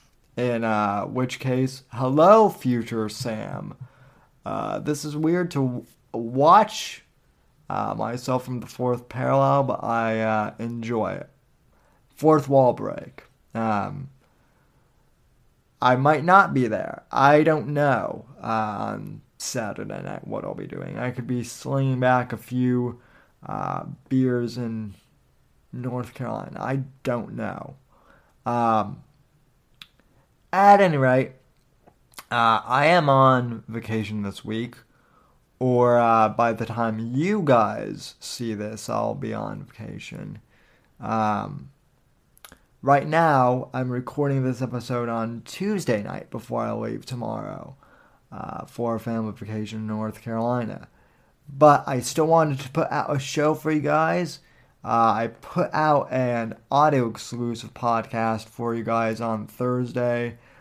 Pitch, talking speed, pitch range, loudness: 125 Hz, 130 wpm, 115-140 Hz, -23 LUFS